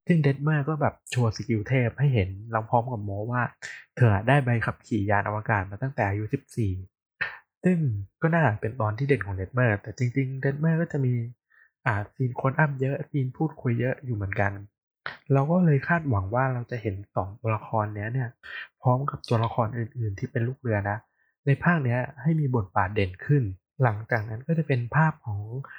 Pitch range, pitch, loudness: 105-135 Hz, 120 Hz, -27 LUFS